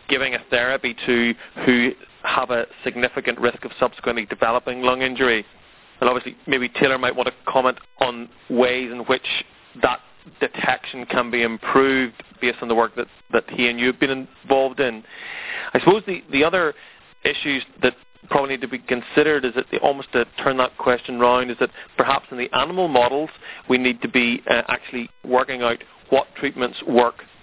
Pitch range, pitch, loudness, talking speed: 120-135 Hz, 125 Hz, -21 LUFS, 180 wpm